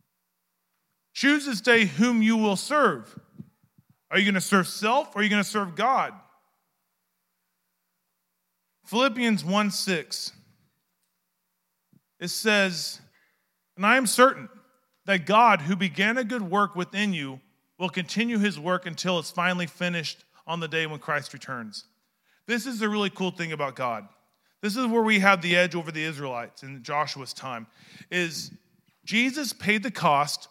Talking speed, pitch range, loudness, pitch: 150 wpm, 145-215 Hz, -24 LUFS, 185 Hz